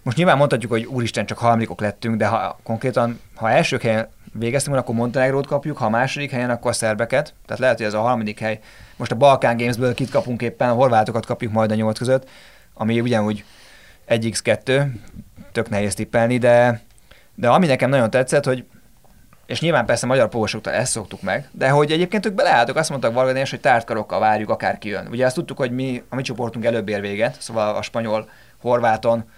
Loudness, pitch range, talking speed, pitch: -20 LUFS, 110-130 Hz, 190 wpm, 120 Hz